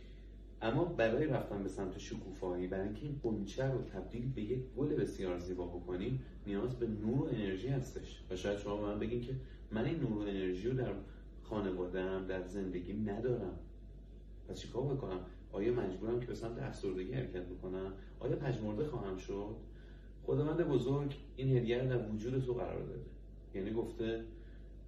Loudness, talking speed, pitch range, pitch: -39 LUFS, 170 wpm, 95-125 Hz, 105 Hz